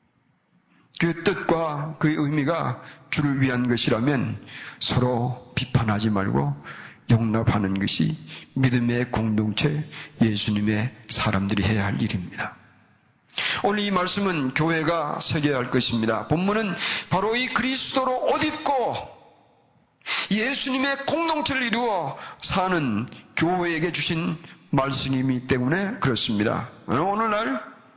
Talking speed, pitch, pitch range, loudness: 245 characters per minute, 150 Hz, 120-185 Hz, -24 LUFS